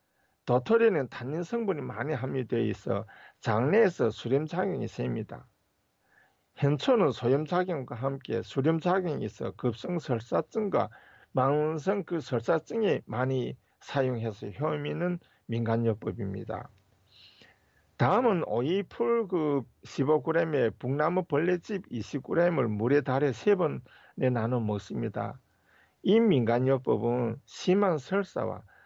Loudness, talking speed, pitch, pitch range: -29 LUFS, 245 characters per minute, 135 Hz, 115-170 Hz